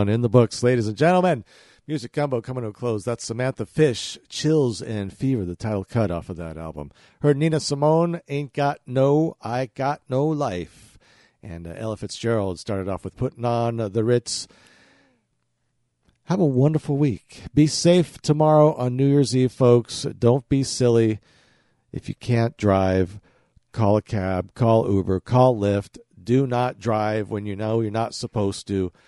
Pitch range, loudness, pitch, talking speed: 105-140 Hz, -22 LUFS, 120 Hz, 165 wpm